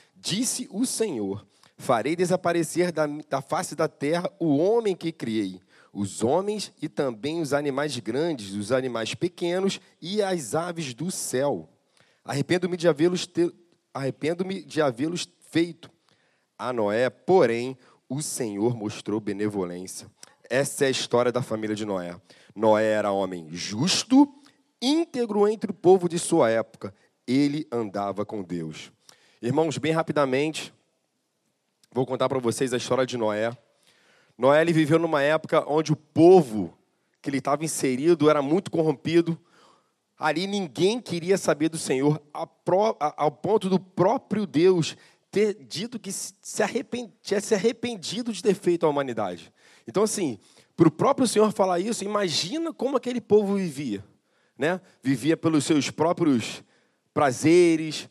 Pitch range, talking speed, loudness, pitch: 130-185 Hz, 135 wpm, -25 LUFS, 160 Hz